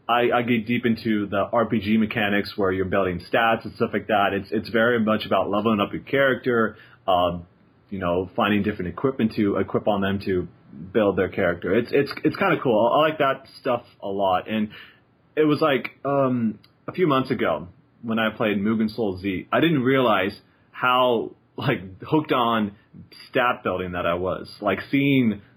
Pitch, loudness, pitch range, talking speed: 110 Hz, -23 LUFS, 100-120 Hz, 190 wpm